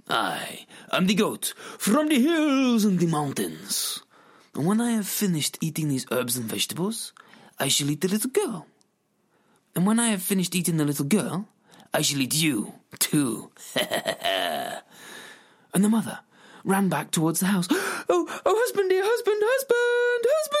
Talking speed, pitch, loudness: 160 wpm, 210 Hz, -24 LUFS